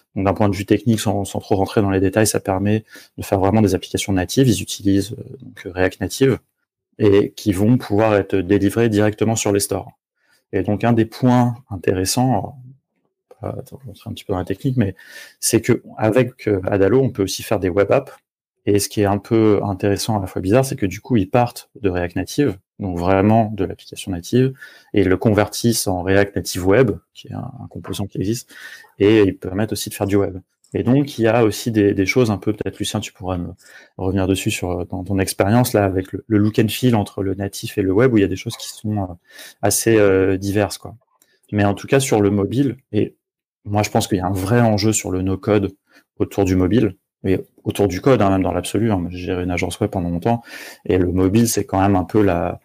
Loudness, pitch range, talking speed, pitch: -19 LUFS, 95-115 Hz, 230 wpm, 100 Hz